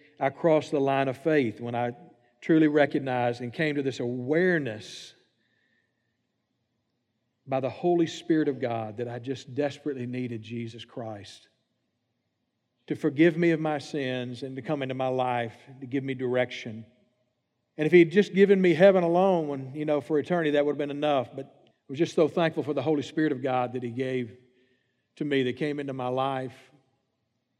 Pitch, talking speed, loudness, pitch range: 135 Hz, 185 wpm, -26 LUFS, 125-155 Hz